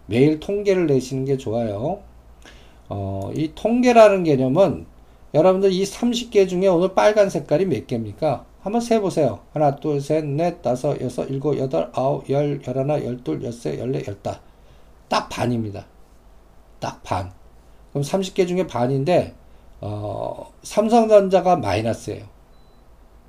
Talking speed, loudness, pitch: 265 characters per minute, -20 LUFS, 135 Hz